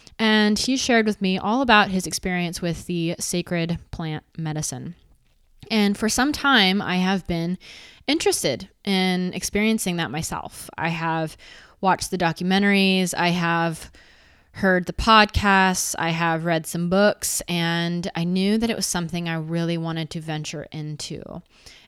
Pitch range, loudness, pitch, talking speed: 165-200 Hz, -22 LUFS, 180 Hz, 150 wpm